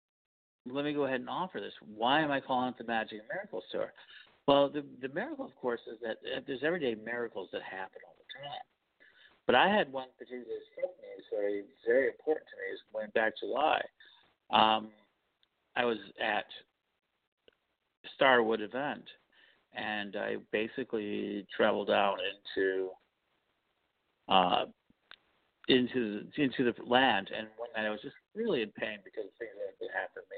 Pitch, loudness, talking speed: 130 Hz, -33 LUFS, 160 wpm